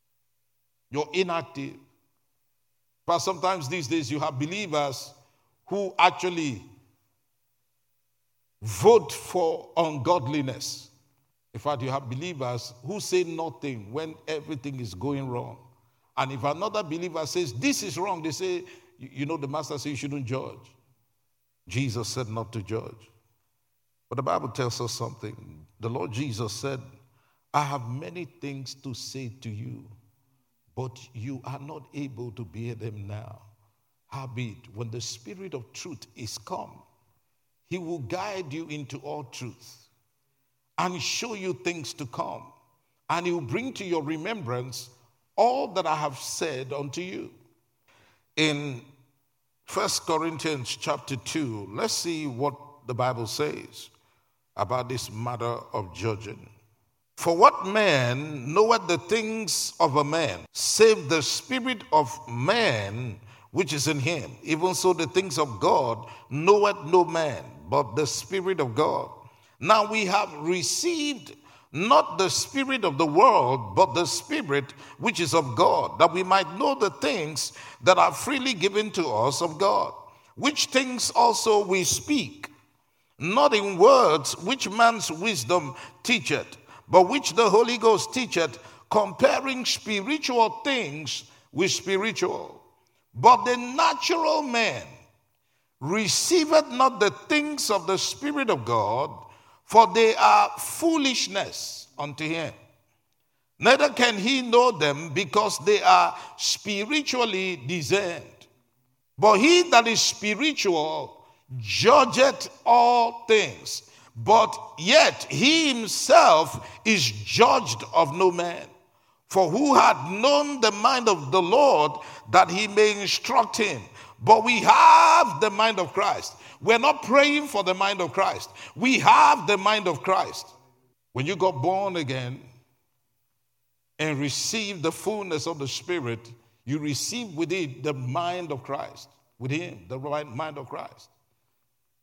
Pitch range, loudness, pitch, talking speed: 125-205 Hz, -23 LUFS, 155 Hz, 135 wpm